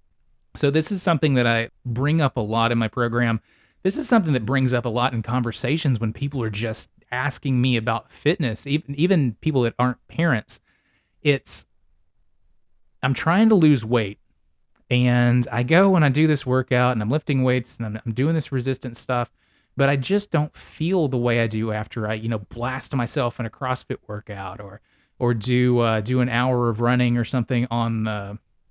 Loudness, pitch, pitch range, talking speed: -22 LUFS, 125 Hz, 115-140 Hz, 195 wpm